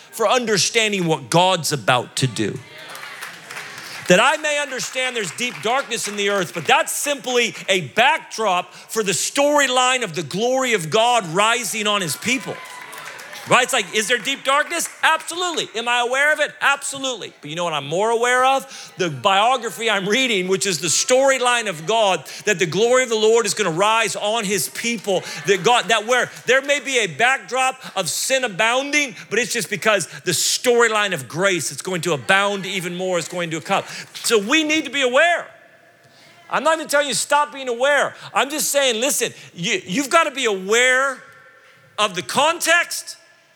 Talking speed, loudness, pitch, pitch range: 185 wpm, -18 LUFS, 230 Hz, 190-270 Hz